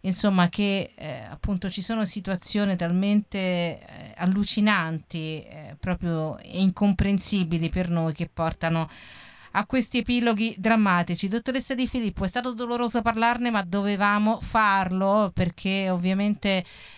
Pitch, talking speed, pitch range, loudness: 195 Hz, 115 wpm, 175-215 Hz, -25 LUFS